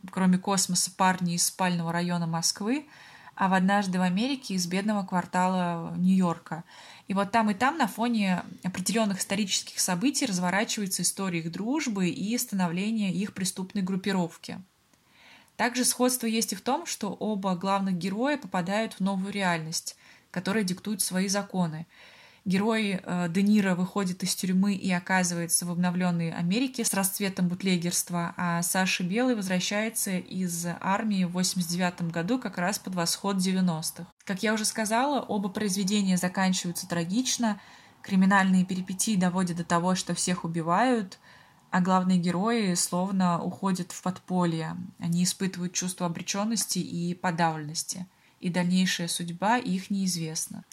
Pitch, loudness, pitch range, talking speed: 185 Hz, -27 LUFS, 180-205 Hz, 135 wpm